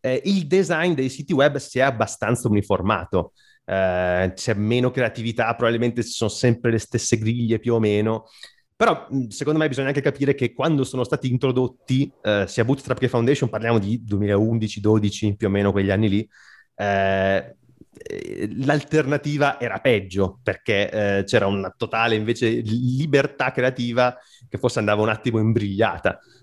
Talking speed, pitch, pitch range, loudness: 150 wpm, 120 Hz, 105-130 Hz, -22 LUFS